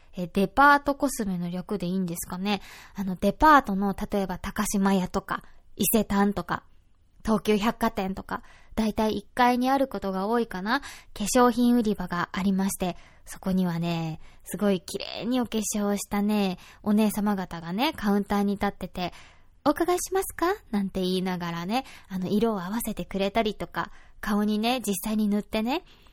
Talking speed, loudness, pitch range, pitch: 335 characters per minute, -26 LUFS, 185-225 Hz, 205 Hz